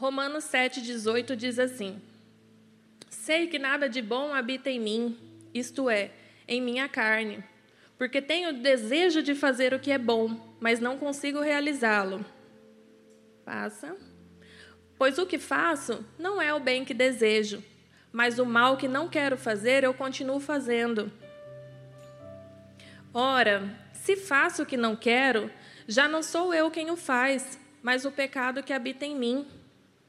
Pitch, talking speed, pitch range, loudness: 255 Hz, 145 wpm, 210-275 Hz, -27 LUFS